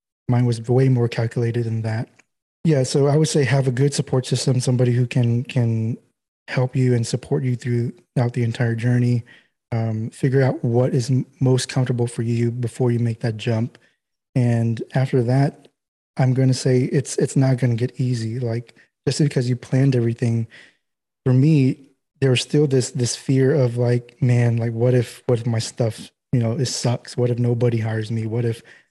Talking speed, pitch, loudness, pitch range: 195 wpm, 125 Hz, -21 LUFS, 120-130 Hz